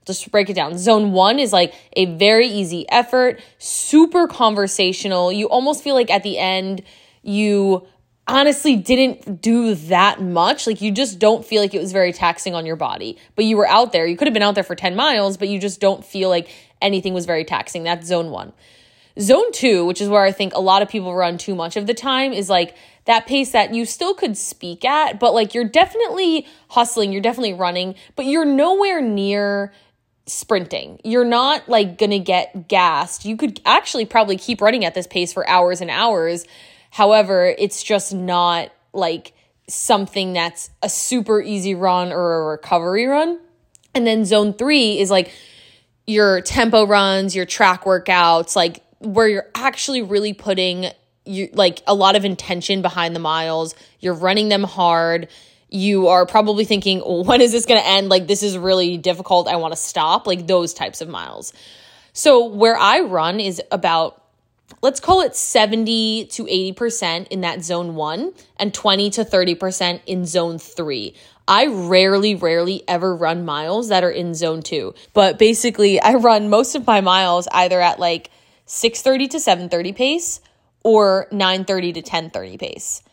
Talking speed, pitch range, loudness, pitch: 180 wpm, 180-225 Hz, -17 LUFS, 195 Hz